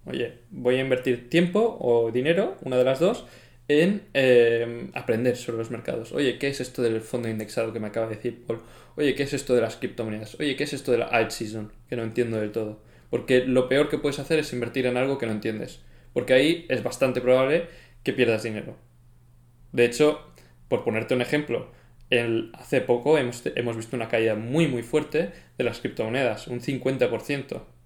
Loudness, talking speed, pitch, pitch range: -25 LUFS, 200 wpm, 120 Hz, 115-135 Hz